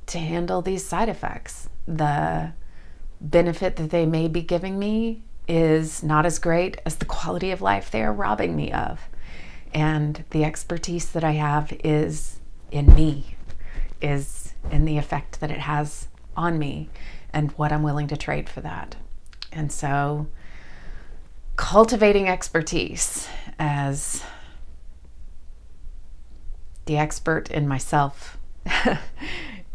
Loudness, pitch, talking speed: -24 LUFS, 150 Hz, 125 wpm